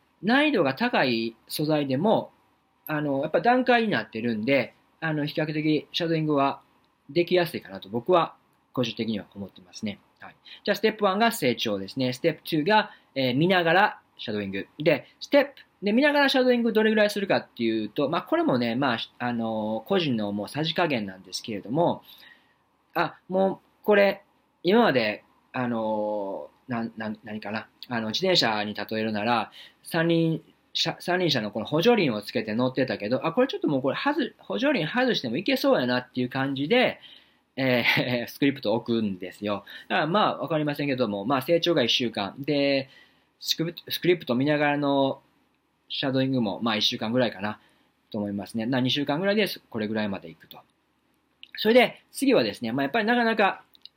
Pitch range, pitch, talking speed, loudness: 115-190 Hz, 140 Hz, 370 characters per minute, -25 LUFS